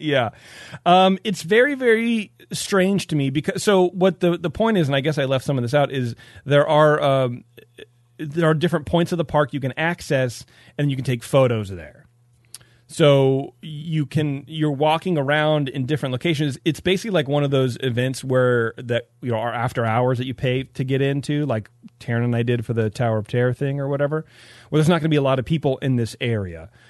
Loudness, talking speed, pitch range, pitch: -21 LUFS, 225 wpm, 125-155 Hz, 140 Hz